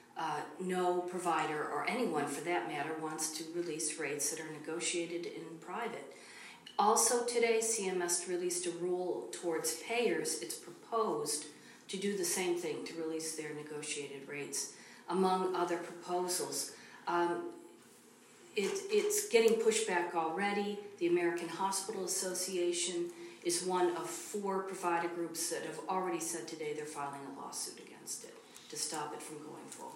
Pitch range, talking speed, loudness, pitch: 165-195 Hz, 145 wpm, -36 LUFS, 175 Hz